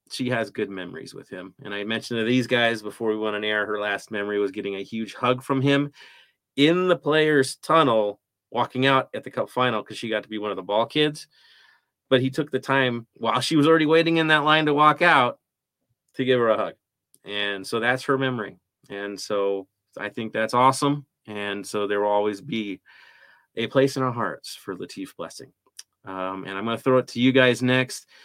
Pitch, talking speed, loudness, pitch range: 120 Hz, 220 wpm, -23 LUFS, 105-135 Hz